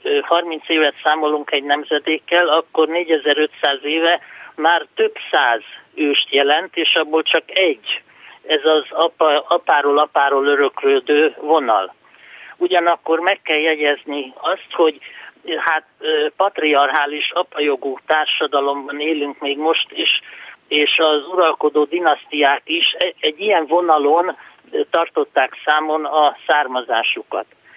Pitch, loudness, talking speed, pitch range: 155 Hz, -17 LUFS, 110 wpm, 145-170 Hz